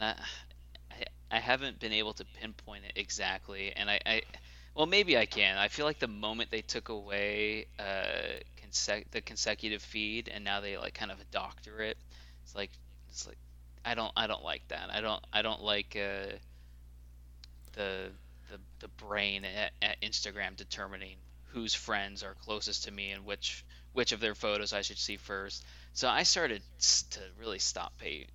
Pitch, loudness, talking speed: 100 Hz, -34 LUFS, 180 wpm